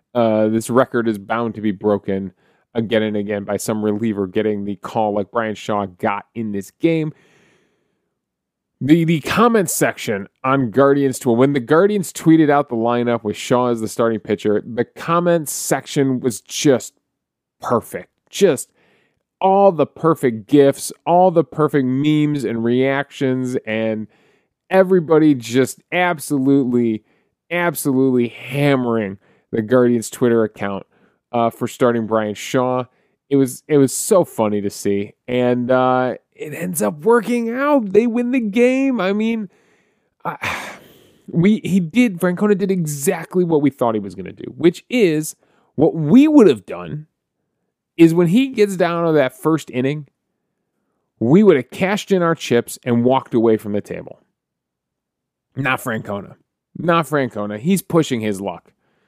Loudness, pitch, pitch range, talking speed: -17 LUFS, 130 Hz, 115-170 Hz, 150 wpm